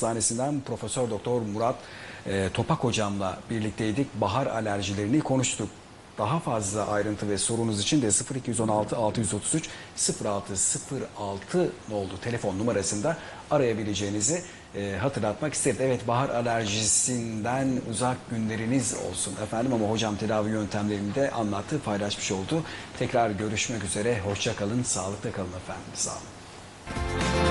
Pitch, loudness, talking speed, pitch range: 110 Hz, -28 LUFS, 115 wpm, 100-120 Hz